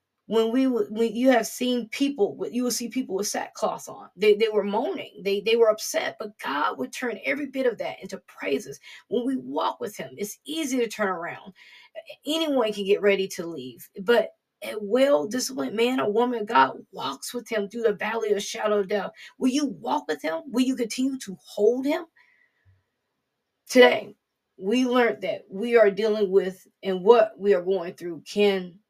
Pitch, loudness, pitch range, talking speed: 225 Hz, -25 LUFS, 200-255 Hz, 195 wpm